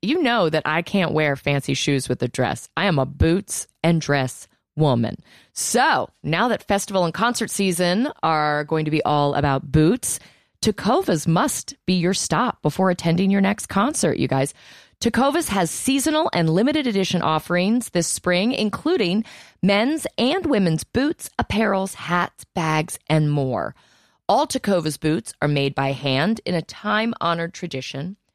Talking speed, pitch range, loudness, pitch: 160 wpm, 150-210 Hz, -21 LUFS, 175 Hz